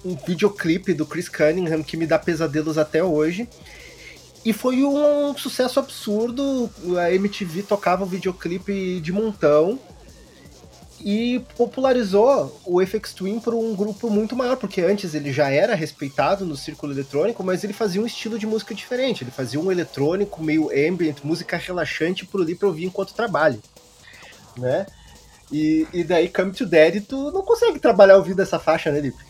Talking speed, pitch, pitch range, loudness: 165 wpm, 185 Hz, 155-220 Hz, -21 LUFS